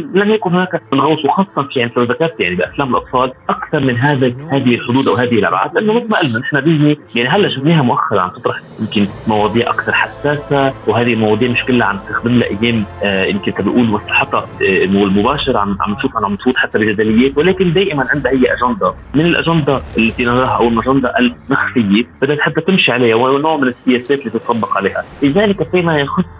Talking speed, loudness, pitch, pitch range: 185 wpm, -14 LUFS, 130 Hz, 115-155 Hz